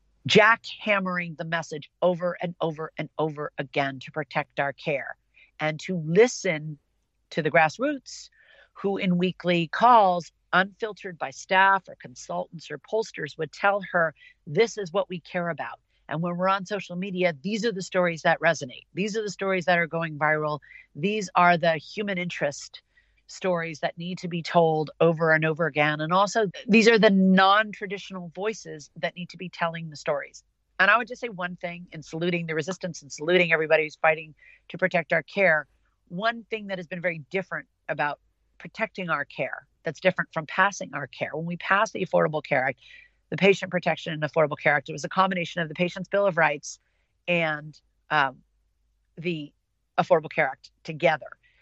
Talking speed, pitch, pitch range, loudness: 185 wpm, 175 Hz, 155-190 Hz, -25 LUFS